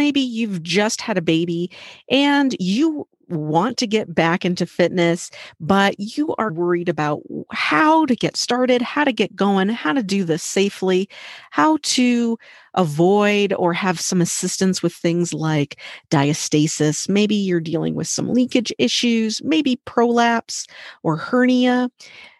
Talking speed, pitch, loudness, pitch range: 145 wpm, 195 Hz, -19 LUFS, 175-245 Hz